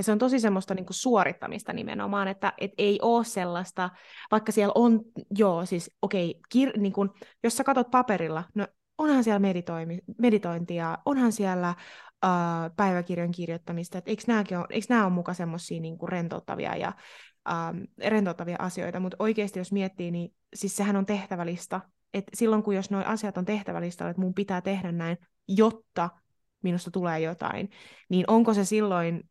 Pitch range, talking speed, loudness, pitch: 175-215 Hz, 155 wpm, -28 LUFS, 195 Hz